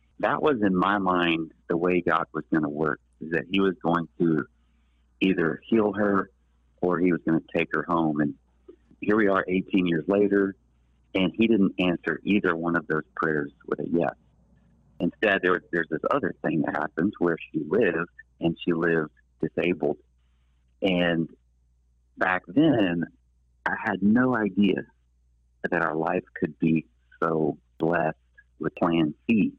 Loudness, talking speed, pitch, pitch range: -26 LUFS, 165 wpm, 85 Hz, 65-95 Hz